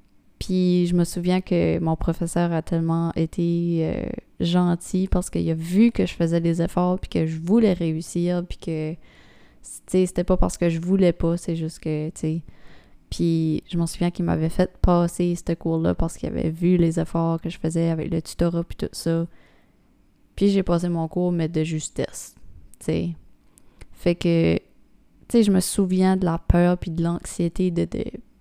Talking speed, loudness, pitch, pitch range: 190 wpm, -23 LUFS, 170 Hz, 165-180 Hz